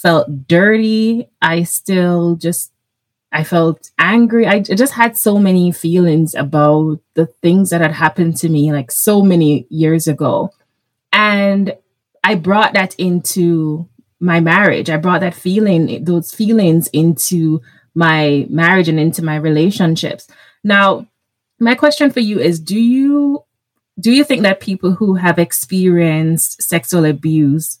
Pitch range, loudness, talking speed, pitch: 155-200 Hz, -13 LUFS, 140 wpm, 170 Hz